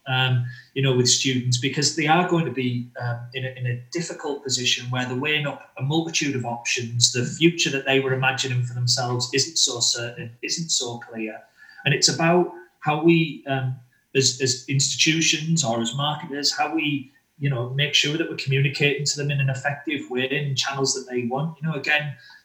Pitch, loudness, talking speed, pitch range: 135 Hz, -22 LUFS, 200 wpm, 125-150 Hz